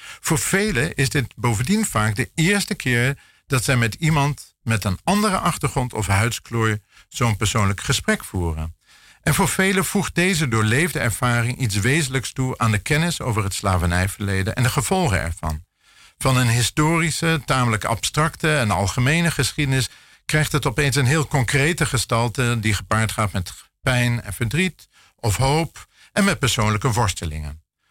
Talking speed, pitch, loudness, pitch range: 155 wpm, 125 Hz, -20 LUFS, 110-150 Hz